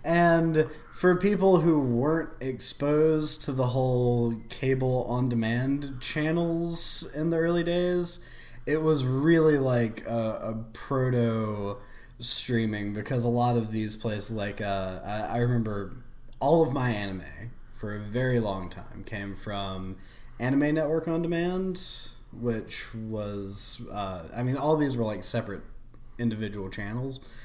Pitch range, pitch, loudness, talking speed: 110-150 Hz, 120 Hz, -27 LUFS, 140 wpm